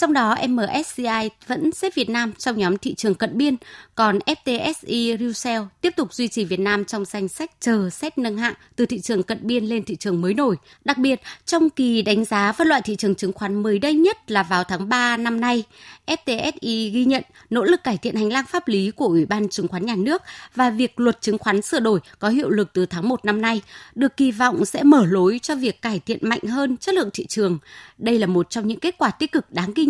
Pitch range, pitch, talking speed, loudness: 205-265 Hz, 230 Hz, 240 wpm, -21 LUFS